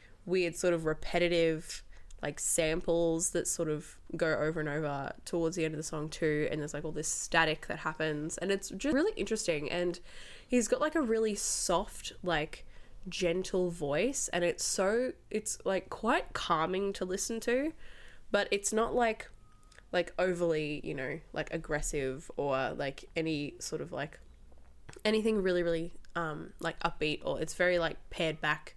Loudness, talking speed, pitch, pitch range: -33 LUFS, 170 wpm, 165 Hz, 155-185 Hz